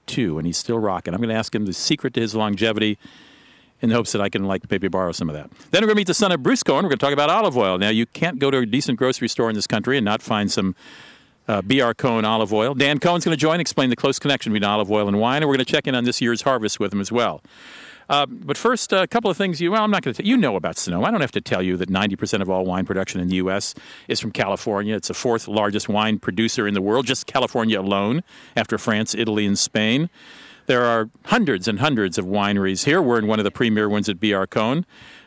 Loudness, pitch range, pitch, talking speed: -20 LUFS, 100-135 Hz, 110 Hz, 295 wpm